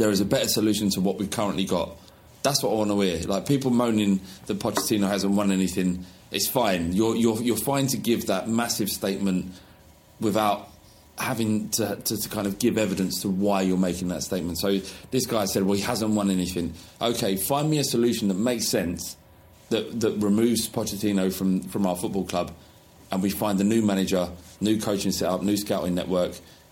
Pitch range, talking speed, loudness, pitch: 95-110 Hz, 200 wpm, -25 LUFS, 100 Hz